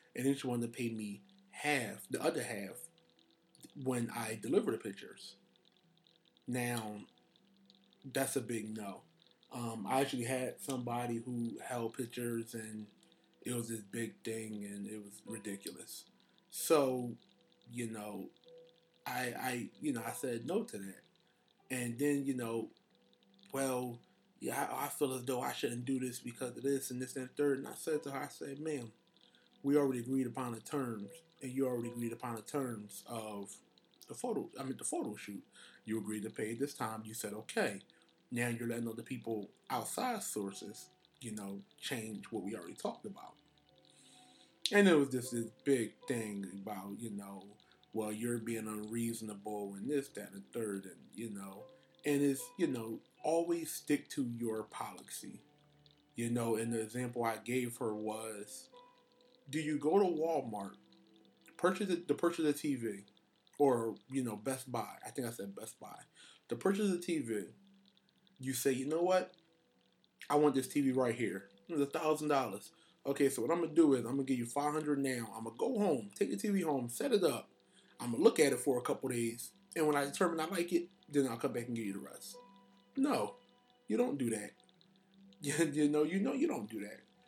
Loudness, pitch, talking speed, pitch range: -37 LUFS, 125 Hz, 185 wpm, 110-150 Hz